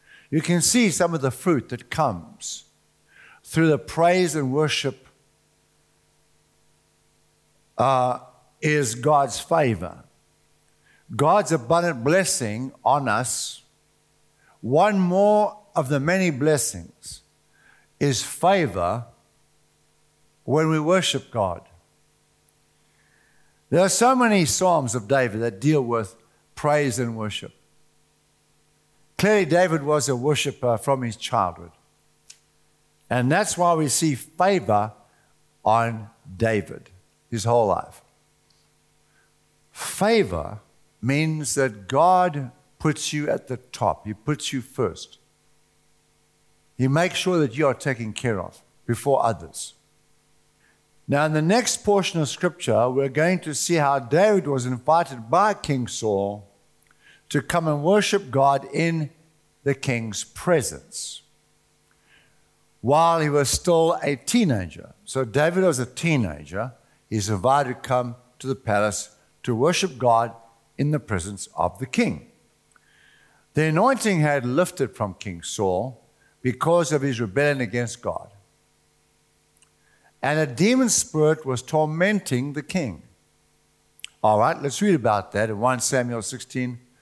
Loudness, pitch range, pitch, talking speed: -22 LUFS, 120-165 Hz, 140 Hz, 120 wpm